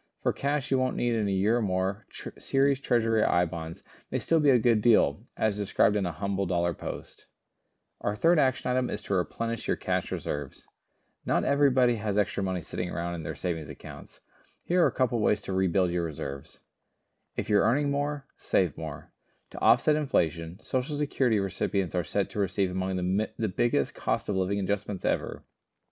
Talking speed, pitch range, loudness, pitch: 195 wpm, 90-125 Hz, -28 LUFS, 100 Hz